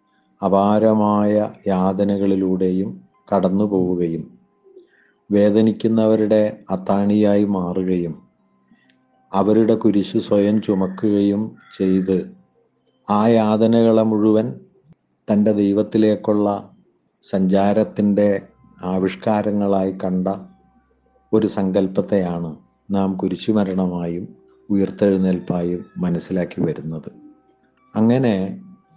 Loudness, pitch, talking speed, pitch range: -19 LUFS, 100 Hz, 60 wpm, 95-110 Hz